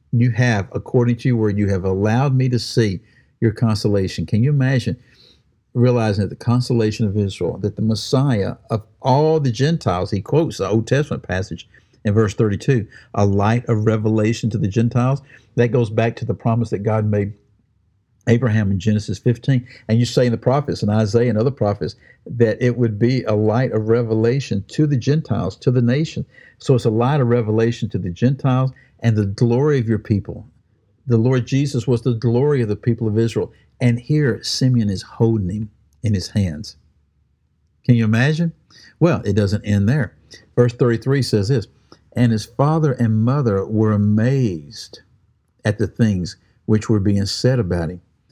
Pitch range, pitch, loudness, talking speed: 105-125 Hz, 115 Hz, -19 LUFS, 185 wpm